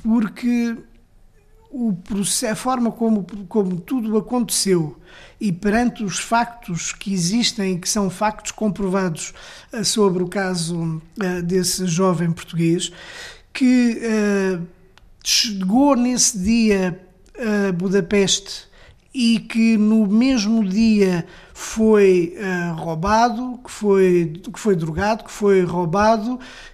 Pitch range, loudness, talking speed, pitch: 185-230 Hz, -19 LUFS, 105 wpm, 205 Hz